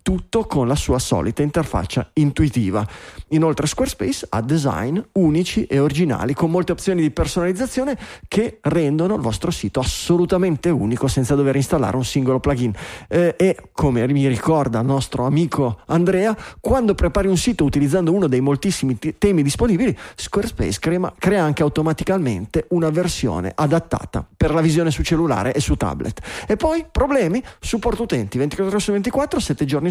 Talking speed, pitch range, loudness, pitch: 160 wpm, 135-185 Hz, -19 LUFS, 160 Hz